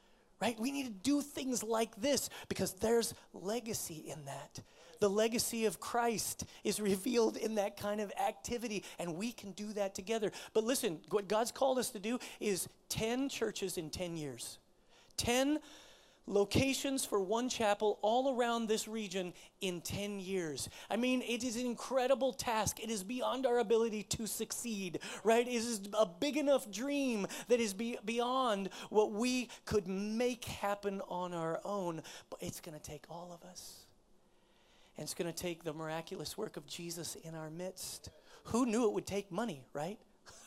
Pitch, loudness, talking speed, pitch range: 215 Hz, -37 LUFS, 175 wpm, 185-240 Hz